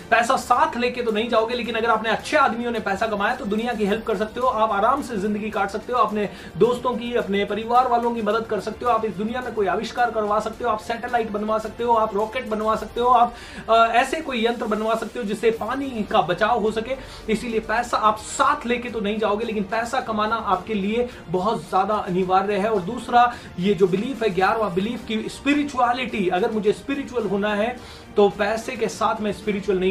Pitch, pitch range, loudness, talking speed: 220 Hz, 210-240 Hz, -22 LUFS, 220 wpm